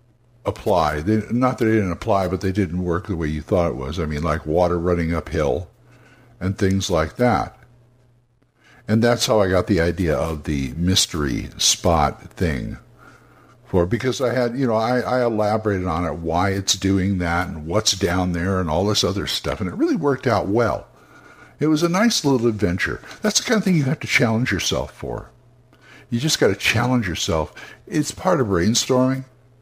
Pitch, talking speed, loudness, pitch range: 110 Hz, 195 wpm, -20 LUFS, 90-125 Hz